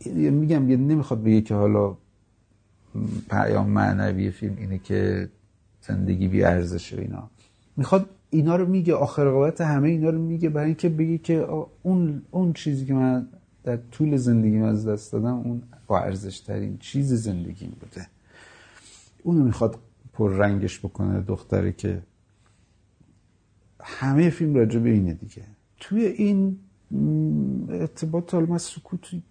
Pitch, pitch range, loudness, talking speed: 115 Hz, 100-150 Hz, -24 LUFS, 135 wpm